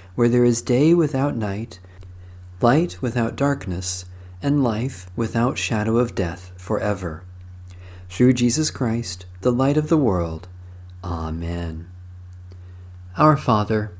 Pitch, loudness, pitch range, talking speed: 95 Hz, -21 LUFS, 90-120 Hz, 115 wpm